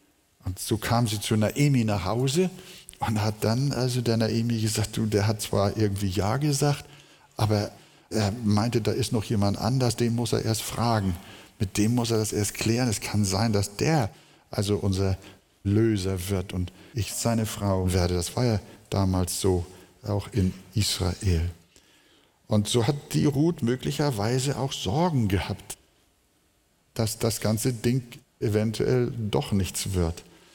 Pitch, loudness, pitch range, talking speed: 110 Hz, -26 LUFS, 100-120 Hz, 160 wpm